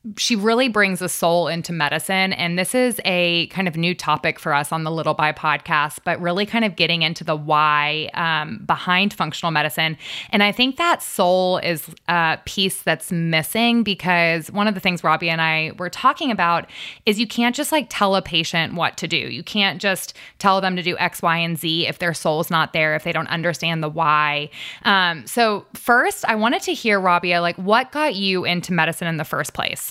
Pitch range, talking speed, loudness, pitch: 160-200 Hz, 215 wpm, -19 LUFS, 175 Hz